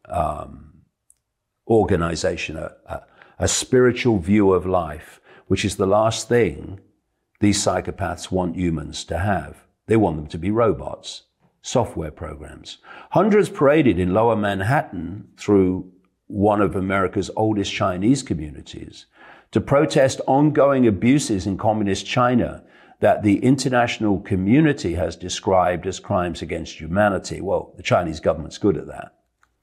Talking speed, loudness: 130 wpm, -20 LUFS